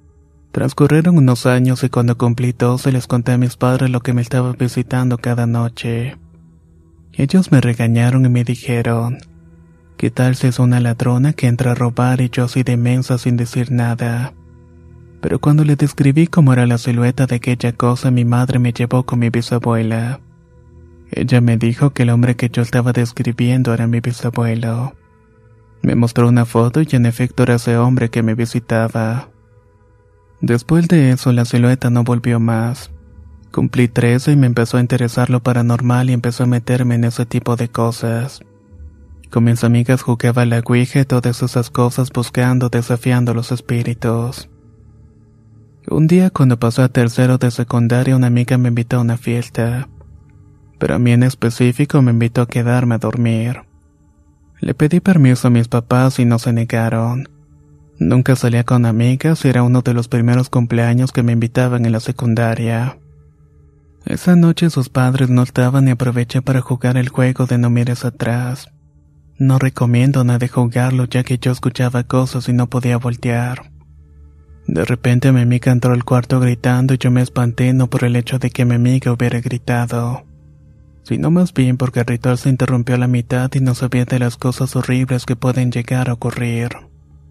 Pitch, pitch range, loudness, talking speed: 120 Hz, 115-125 Hz, -15 LUFS, 175 wpm